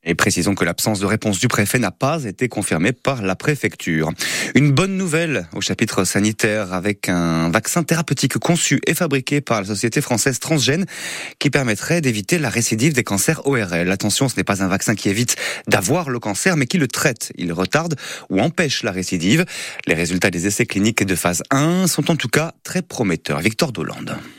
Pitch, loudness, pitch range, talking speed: 115 Hz, -19 LUFS, 100-140 Hz, 190 wpm